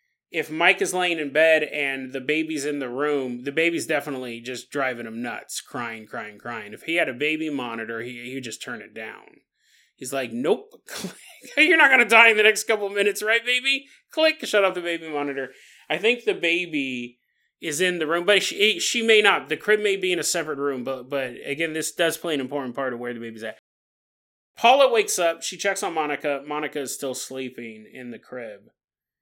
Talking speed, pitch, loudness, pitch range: 220 wpm, 155 Hz, -22 LUFS, 130-200 Hz